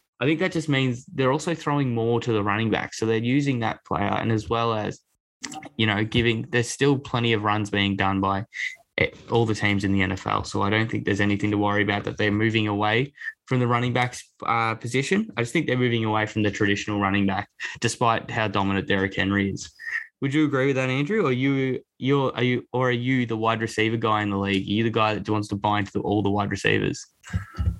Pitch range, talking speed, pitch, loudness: 105-125 Hz, 235 wpm, 110 Hz, -24 LUFS